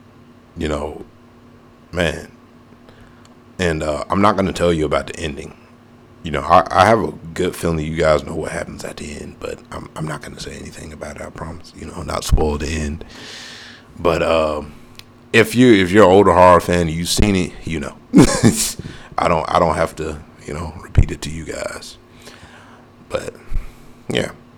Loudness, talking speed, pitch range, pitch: -17 LUFS, 190 wpm, 80-120 Hz, 85 Hz